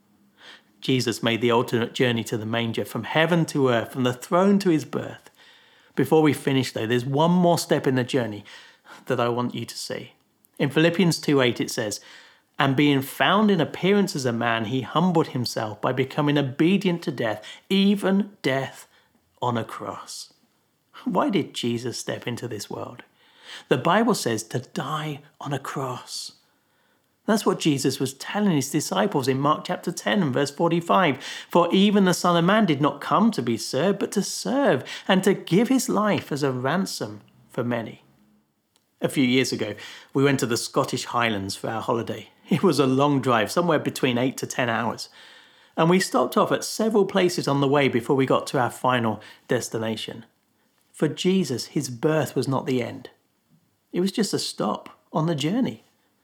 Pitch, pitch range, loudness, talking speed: 145 Hz, 125-180 Hz, -23 LUFS, 185 wpm